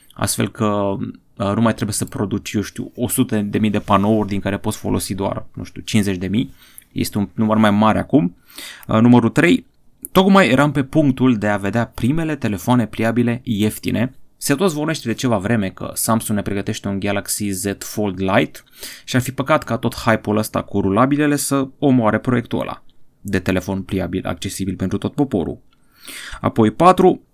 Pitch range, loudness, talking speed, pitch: 100-125 Hz, -18 LUFS, 180 wpm, 110 Hz